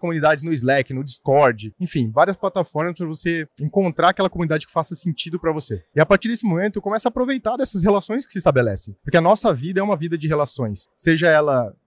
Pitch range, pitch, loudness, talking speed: 150-195 Hz, 170 Hz, -20 LUFS, 210 wpm